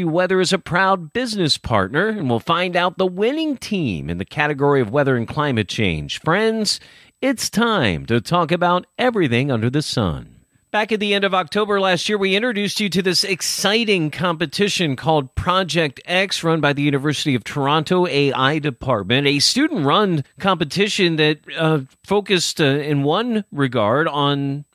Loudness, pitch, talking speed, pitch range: -19 LUFS, 165 Hz, 165 wpm, 140-195 Hz